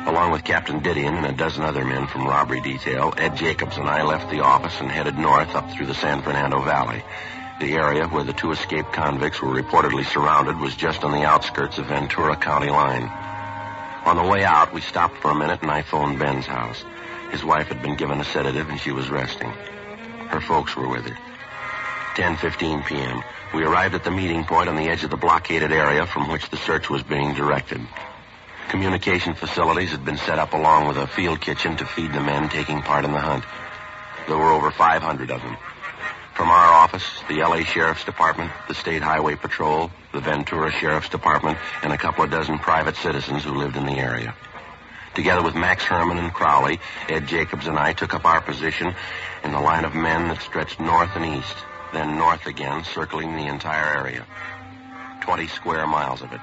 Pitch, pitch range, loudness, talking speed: 75 Hz, 70-80 Hz, -21 LUFS, 200 wpm